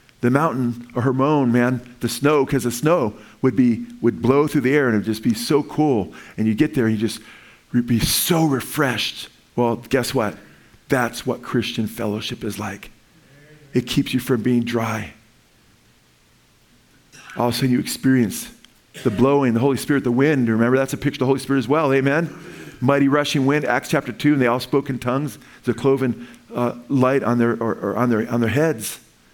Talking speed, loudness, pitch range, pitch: 200 wpm, -20 LUFS, 120-140 Hz, 125 Hz